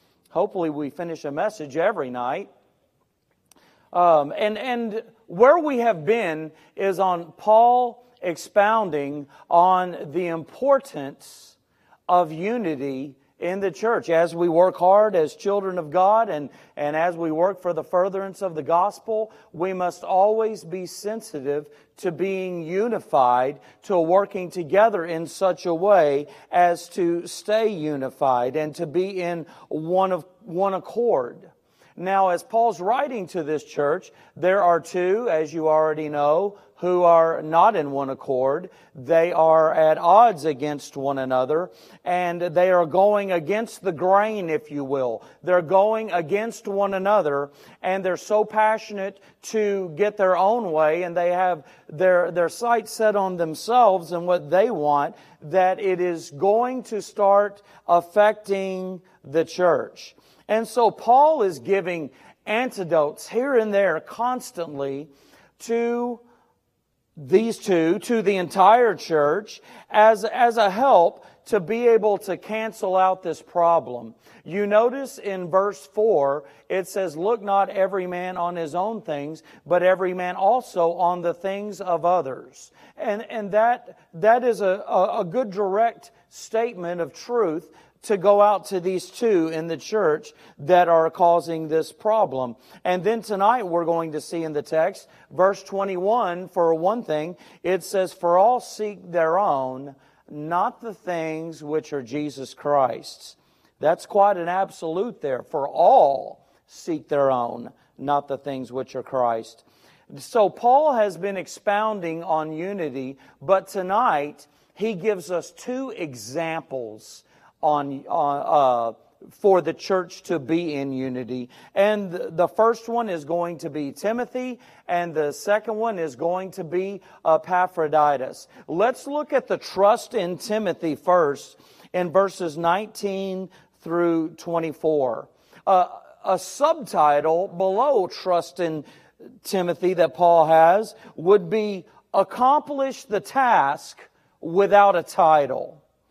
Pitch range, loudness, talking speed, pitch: 160-205 Hz, -22 LUFS, 140 wpm, 180 Hz